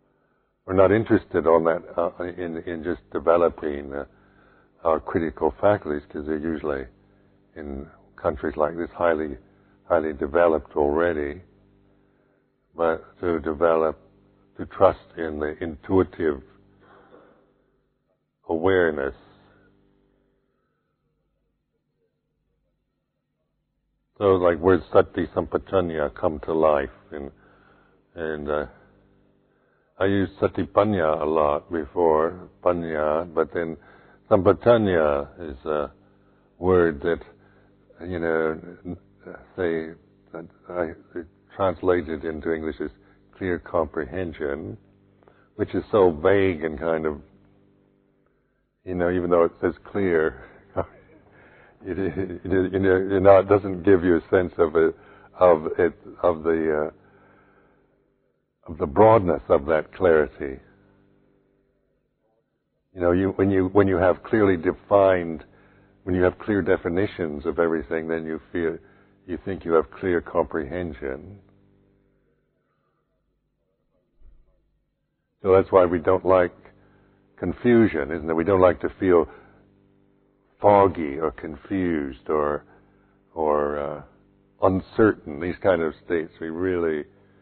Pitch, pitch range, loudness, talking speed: 95 Hz, 80-100 Hz, -23 LUFS, 110 wpm